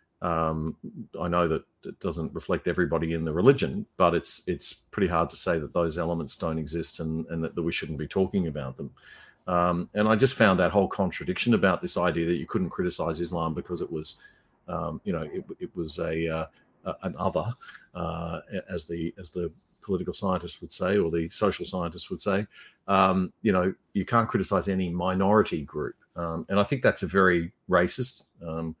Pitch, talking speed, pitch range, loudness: 85 Hz, 200 wpm, 80-95 Hz, -27 LUFS